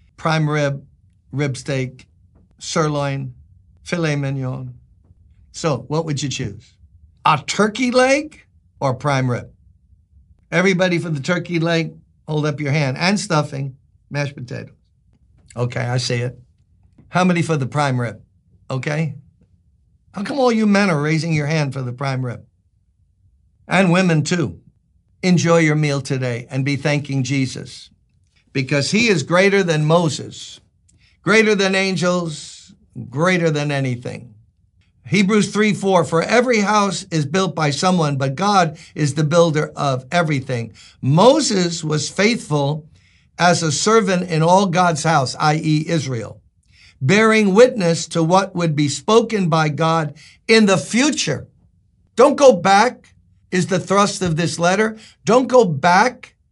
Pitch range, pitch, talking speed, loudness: 120-180 Hz, 150 Hz, 140 wpm, -18 LUFS